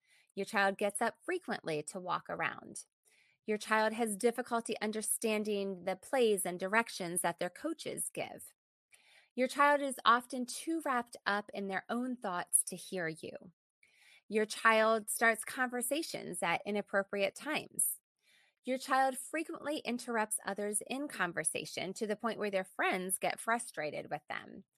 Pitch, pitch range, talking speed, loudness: 220 Hz, 195-250 Hz, 145 wpm, -35 LUFS